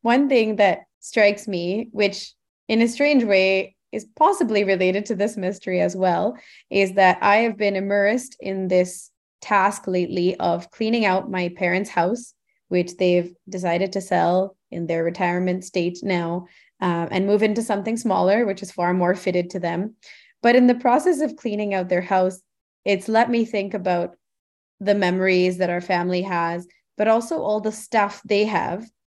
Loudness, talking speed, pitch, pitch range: -21 LUFS, 175 wpm, 195 Hz, 180-215 Hz